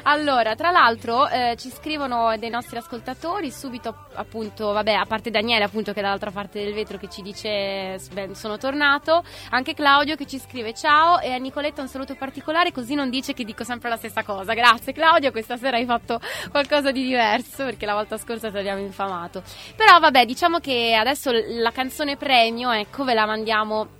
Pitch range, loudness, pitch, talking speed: 220-275 Hz, -21 LUFS, 240 Hz, 195 wpm